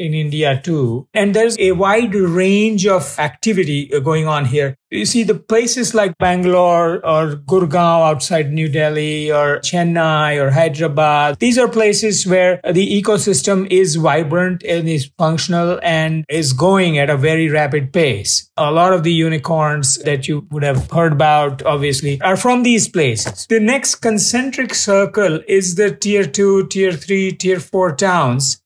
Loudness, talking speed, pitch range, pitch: -15 LUFS, 160 wpm, 150-195 Hz, 170 Hz